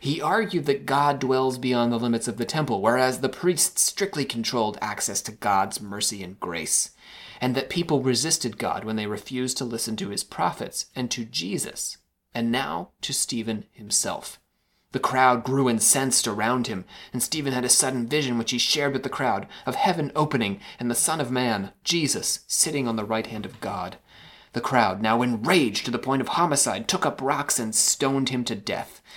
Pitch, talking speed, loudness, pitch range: 125 Hz, 195 wpm, -24 LUFS, 115-140 Hz